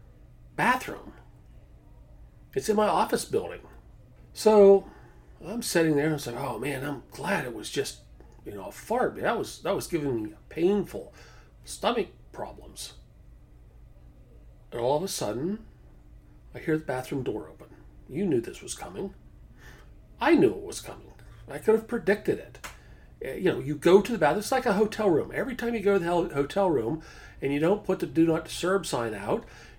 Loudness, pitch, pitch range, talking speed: -27 LUFS, 160 Hz, 120-205 Hz, 185 wpm